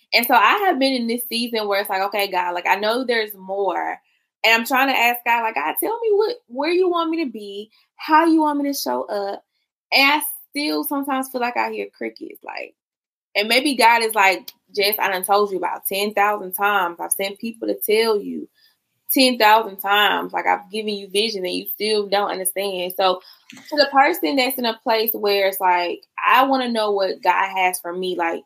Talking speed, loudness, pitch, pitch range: 225 wpm, -19 LUFS, 220 Hz, 200-275 Hz